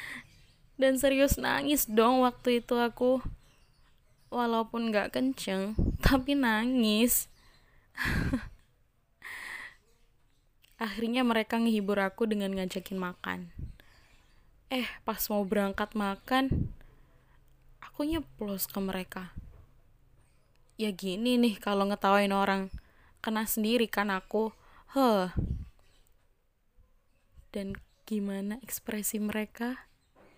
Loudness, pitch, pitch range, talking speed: -30 LUFS, 215 Hz, 190-240 Hz, 85 wpm